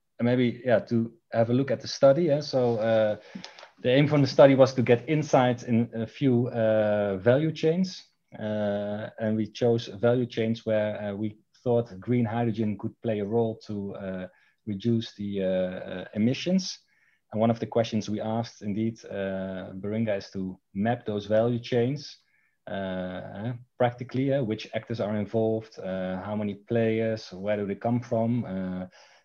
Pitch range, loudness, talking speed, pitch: 105-120 Hz, -27 LUFS, 170 wpm, 115 Hz